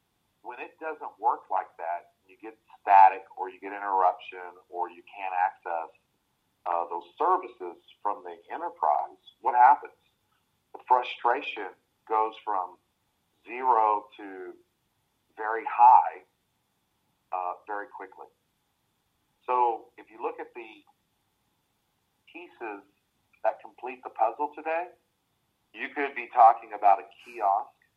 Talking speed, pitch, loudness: 120 wpm, 160 Hz, -26 LUFS